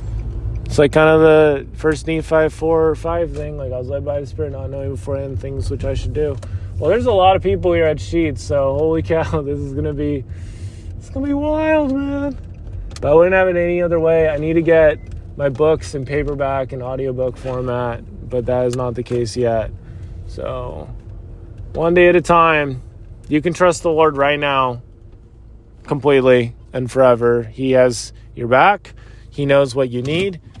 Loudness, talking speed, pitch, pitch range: -17 LUFS, 195 wpm, 135 Hz, 110-155 Hz